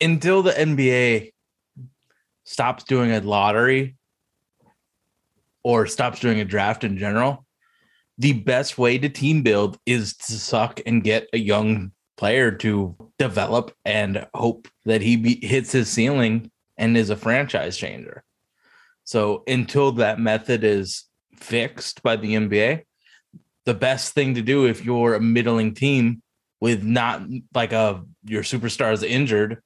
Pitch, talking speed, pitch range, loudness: 115 Hz, 140 wpm, 110-130 Hz, -21 LUFS